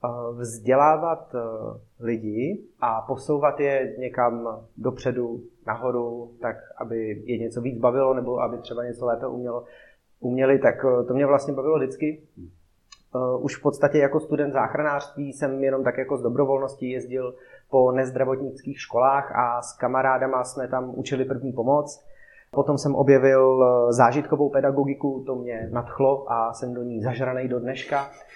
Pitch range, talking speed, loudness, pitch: 120-140 Hz, 140 wpm, -24 LUFS, 130 Hz